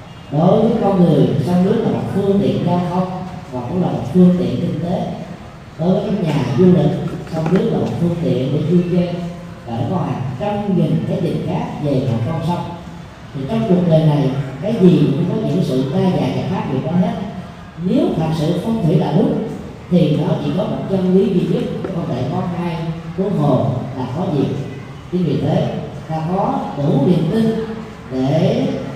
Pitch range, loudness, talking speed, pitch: 150-185 Hz, -17 LUFS, 205 wpm, 170 Hz